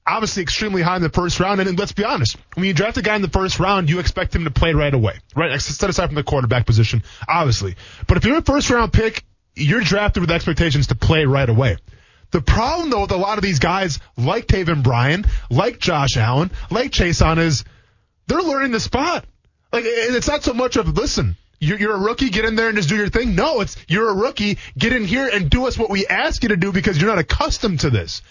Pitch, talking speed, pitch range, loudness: 180 Hz, 245 wpm, 135-215 Hz, -18 LUFS